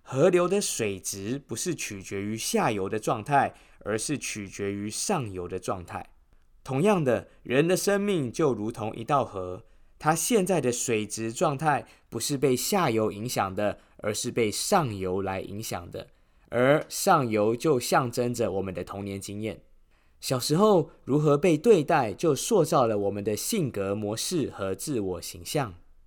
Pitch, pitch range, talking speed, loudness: 110 Hz, 95-145 Hz, 235 characters per minute, -27 LUFS